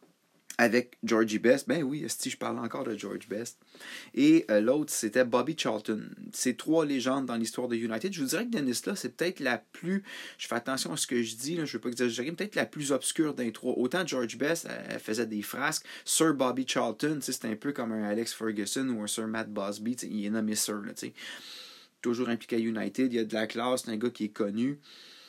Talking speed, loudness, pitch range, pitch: 235 wpm, -30 LUFS, 110-140 Hz, 120 Hz